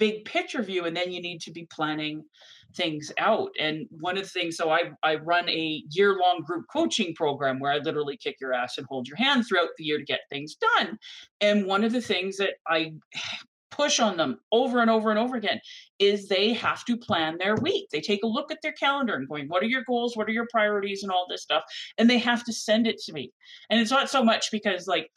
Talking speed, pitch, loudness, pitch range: 245 wpm, 200 Hz, -26 LUFS, 165-235 Hz